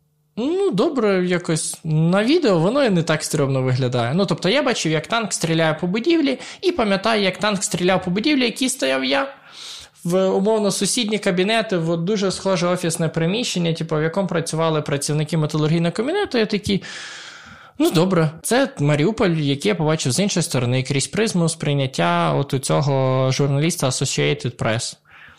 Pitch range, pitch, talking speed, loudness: 150-205 Hz, 170 Hz, 160 wpm, -20 LUFS